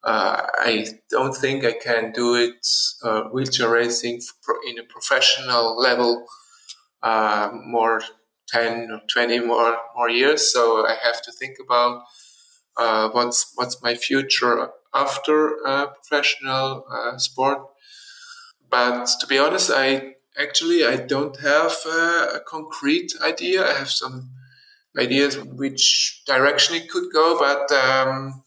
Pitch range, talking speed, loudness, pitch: 120-155 Hz, 130 wpm, -20 LUFS, 130 Hz